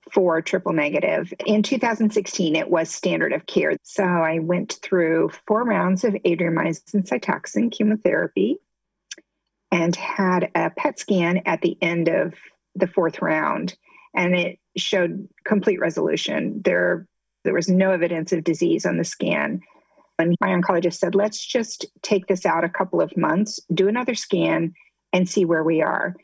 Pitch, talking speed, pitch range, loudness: 185 Hz, 155 wpm, 170-210 Hz, -22 LUFS